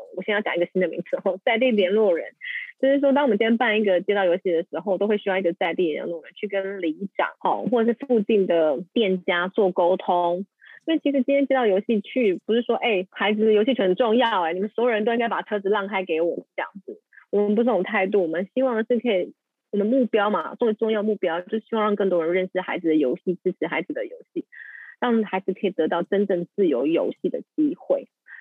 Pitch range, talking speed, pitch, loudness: 185-240 Hz, 355 characters per minute, 205 Hz, -23 LUFS